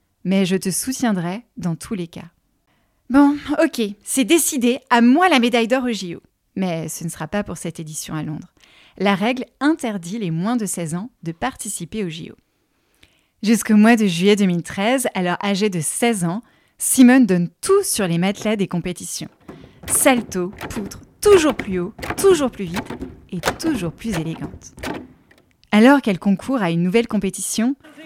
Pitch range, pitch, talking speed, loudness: 180-250 Hz, 210 Hz, 165 wpm, -19 LUFS